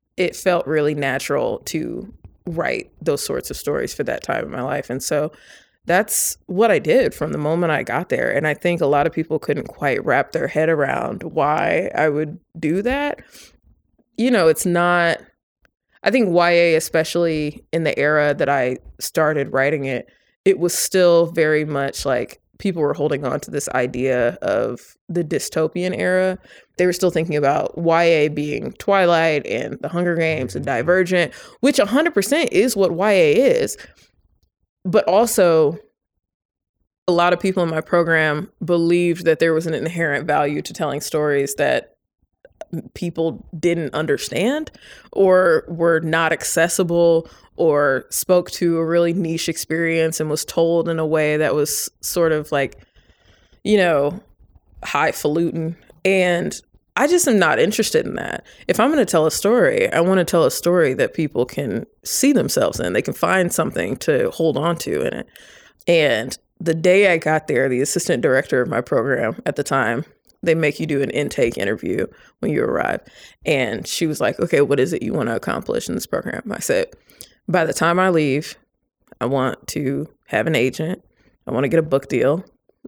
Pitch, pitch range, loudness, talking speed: 165 Hz, 150-180 Hz, -19 LUFS, 175 wpm